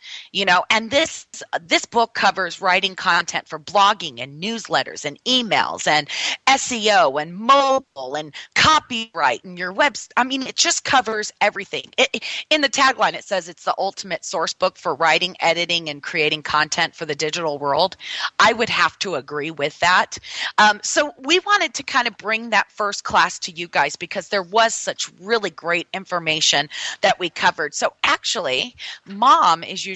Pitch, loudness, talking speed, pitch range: 195 Hz, -19 LUFS, 175 wpm, 165-240 Hz